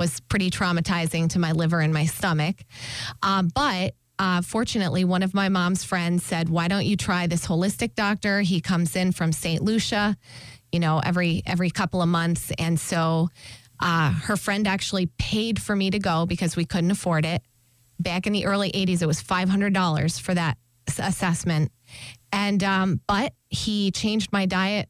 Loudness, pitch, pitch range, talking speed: -24 LUFS, 175 Hz, 165-195 Hz, 180 wpm